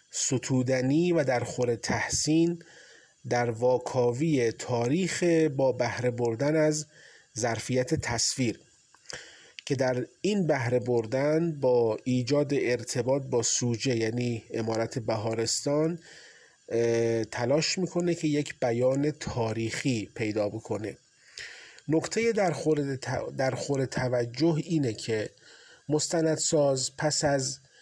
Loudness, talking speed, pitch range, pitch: -28 LUFS, 95 wpm, 120-155 Hz, 130 Hz